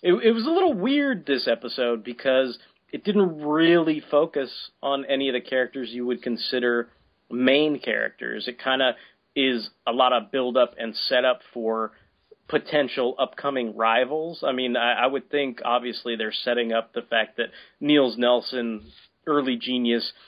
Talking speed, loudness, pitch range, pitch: 160 wpm, -24 LUFS, 120-145 Hz, 125 Hz